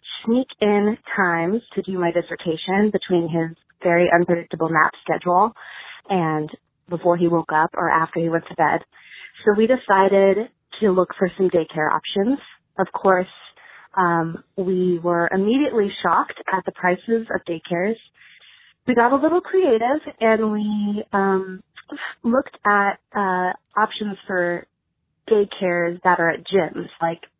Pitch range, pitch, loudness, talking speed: 170-210 Hz, 190 Hz, -20 LUFS, 140 wpm